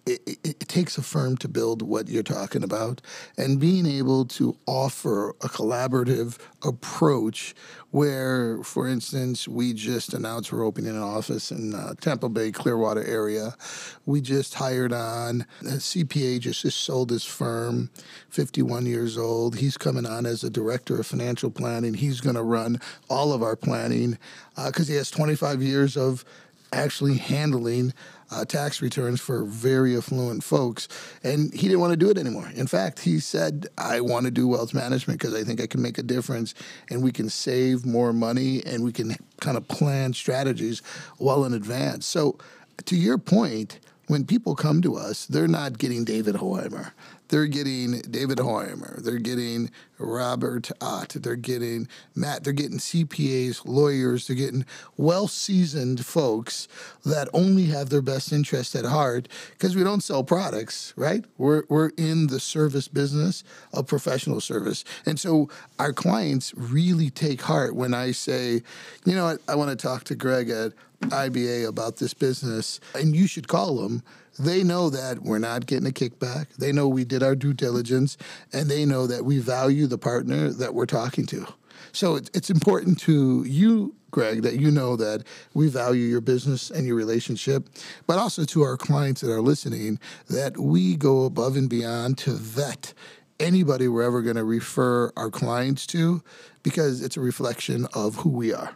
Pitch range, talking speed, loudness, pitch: 120-150 Hz, 175 wpm, -25 LUFS, 130 Hz